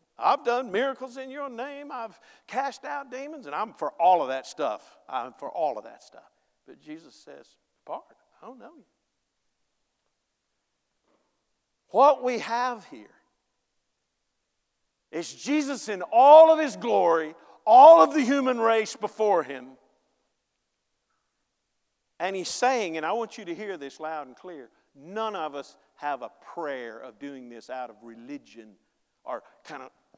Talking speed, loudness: 155 wpm, -23 LUFS